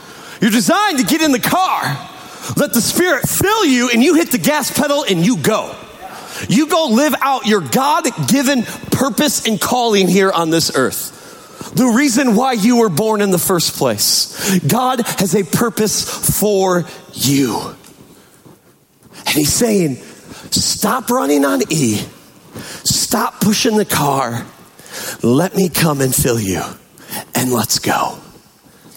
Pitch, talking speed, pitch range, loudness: 215 Hz, 145 wpm, 165-255 Hz, -14 LUFS